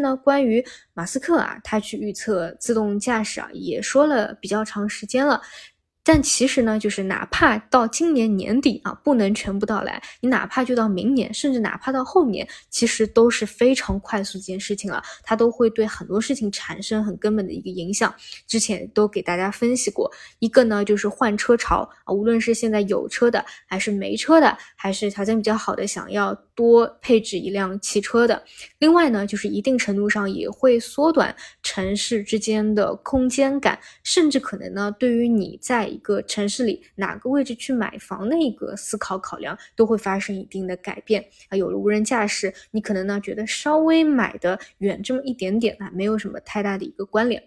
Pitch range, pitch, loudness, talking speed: 200-250 Hz, 220 Hz, -21 LUFS, 295 characters per minute